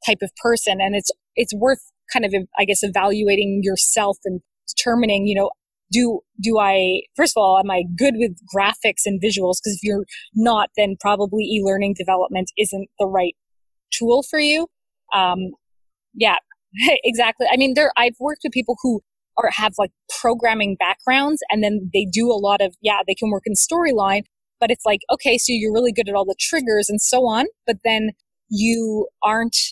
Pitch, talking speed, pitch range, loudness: 210 Hz, 185 wpm, 195-240 Hz, -19 LUFS